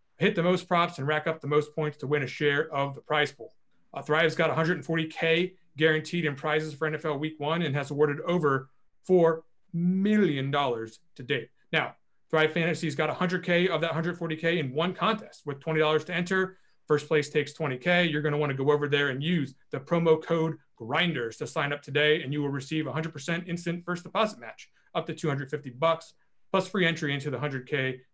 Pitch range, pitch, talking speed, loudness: 145-170 Hz, 155 Hz, 200 wpm, -28 LUFS